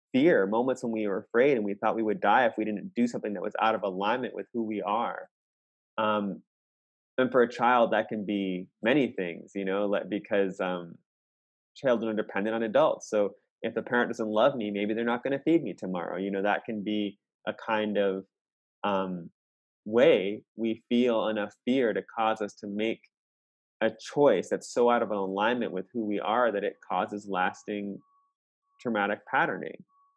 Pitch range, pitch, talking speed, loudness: 100-115 Hz, 105 Hz, 190 wpm, -28 LUFS